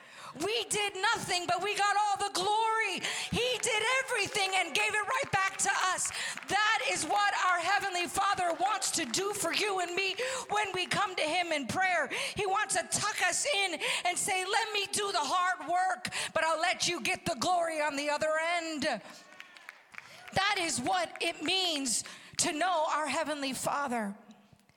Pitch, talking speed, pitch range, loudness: 370 Hz, 180 wpm, 330-410 Hz, -30 LUFS